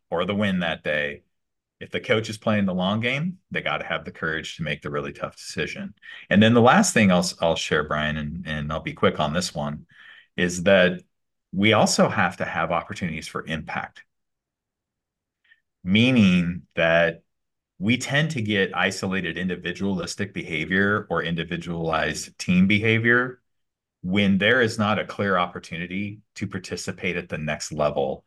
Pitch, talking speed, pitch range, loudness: 95 Hz, 165 wpm, 85-105 Hz, -23 LUFS